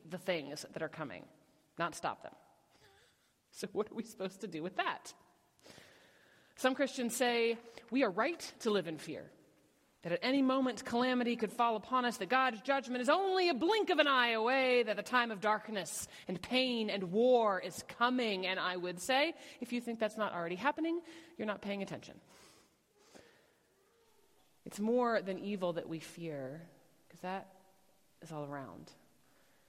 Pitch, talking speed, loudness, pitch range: 225 Hz, 170 wpm, -35 LUFS, 185-255 Hz